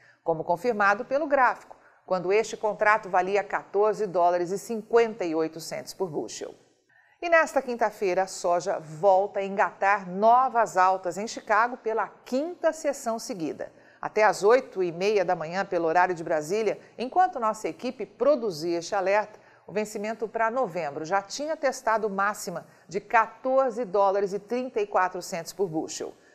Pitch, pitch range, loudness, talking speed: 210 Hz, 185-235 Hz, -26 LUFS, 130 wpm